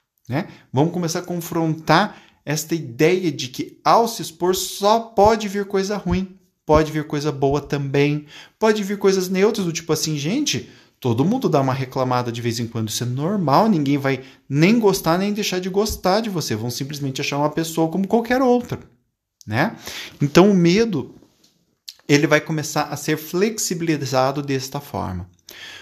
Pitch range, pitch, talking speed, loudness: 140-190 Hz, 160 Hz, 165 wpm, -20 LUFS